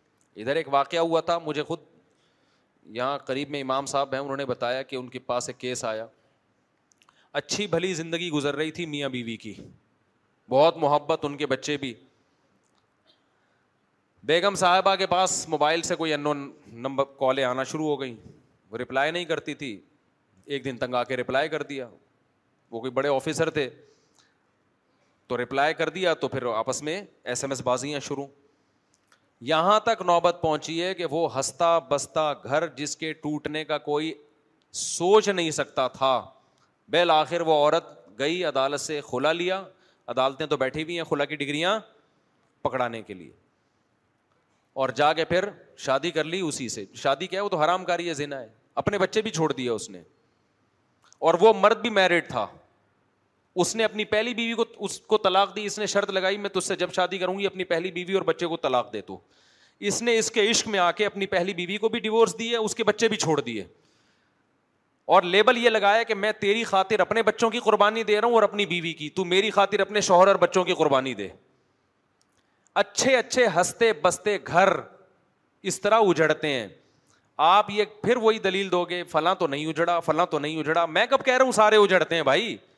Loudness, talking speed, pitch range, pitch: -24 LUFS, 195 wpm, 140-195 Hz, 165 Hz